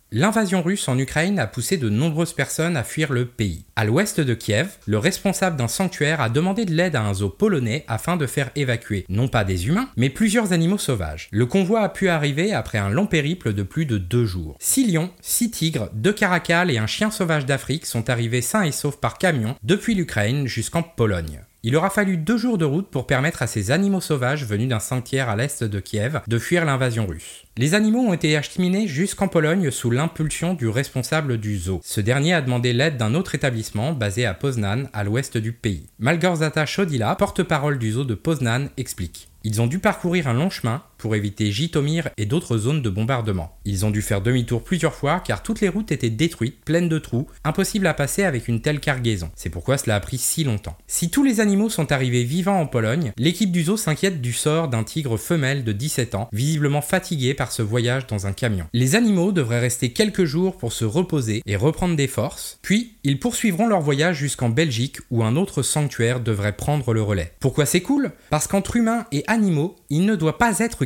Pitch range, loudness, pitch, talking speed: 115-175 Hz, -21 LUFS, 140 Hz, 215 wpm